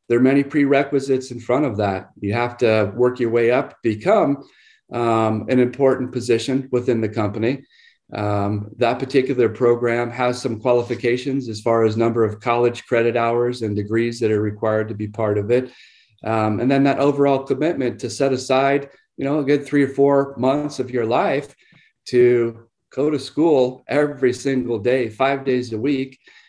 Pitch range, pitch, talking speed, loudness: 115-135 Hz, 125 Hz, 180 wpm, -20 LUFS